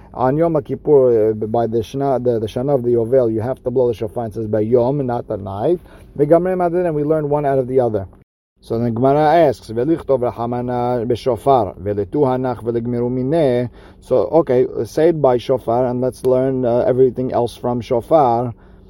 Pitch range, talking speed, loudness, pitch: 115-135 Hz, 165 wpm, -17 LUFS, 125 Hz